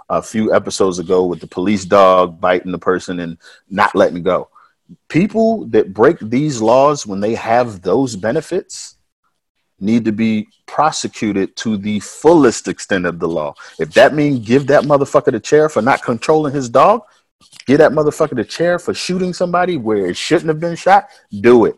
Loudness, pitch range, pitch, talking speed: -15 LUFS, 105-160 Hz, 135 Hz, 180 wpm